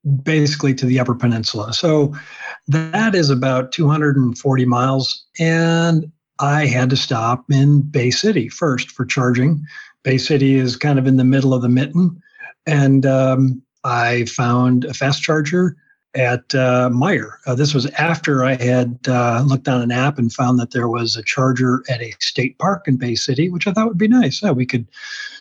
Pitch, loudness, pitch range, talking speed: 135 Hz, -17 LUFS, 125-150 Hz, 185 wpm